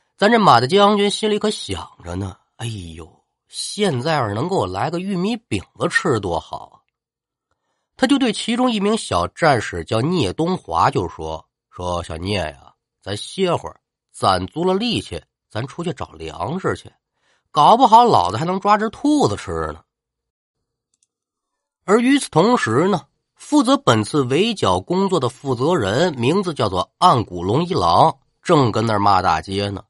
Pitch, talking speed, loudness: 150 Hz, 230 characters per minute, -18 LUFS